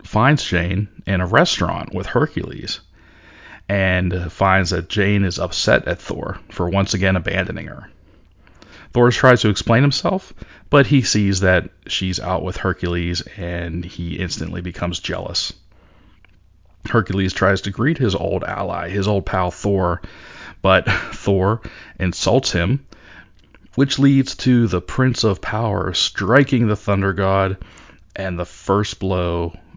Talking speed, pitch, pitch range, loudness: 135 wpm, 95 Hz, 90-105 Hz, -19 LUFS